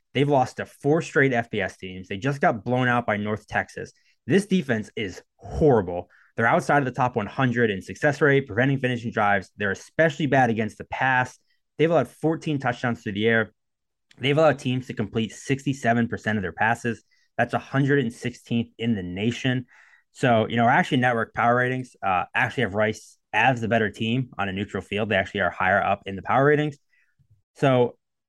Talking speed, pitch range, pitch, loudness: 185 wpm, 110-135 Hz, 120 Hz, -24 LUFS